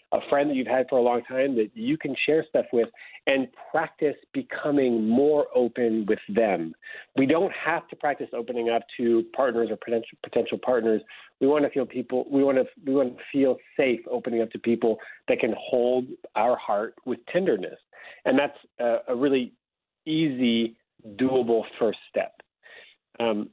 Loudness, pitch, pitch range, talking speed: -25 LUFS, 125 Hz, 115-140 Hz, 175 wpm